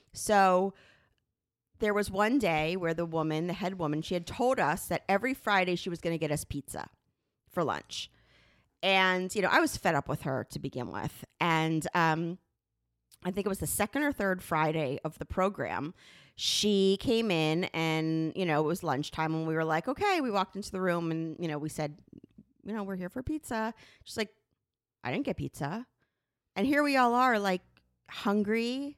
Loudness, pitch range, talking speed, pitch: -30 LUFS, 160-210 Hz, 195 wpm, 180 Hz